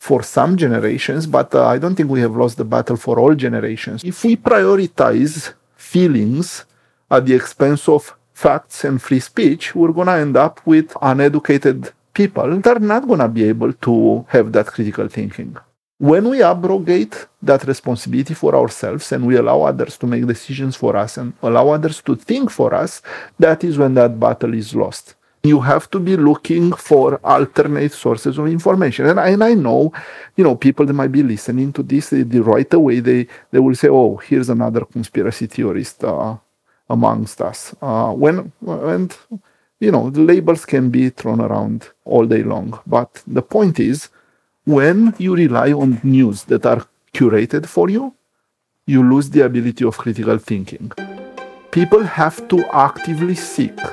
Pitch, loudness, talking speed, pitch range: 145 Hz, -15 LUFS, 175 wpm, 125-170 Hz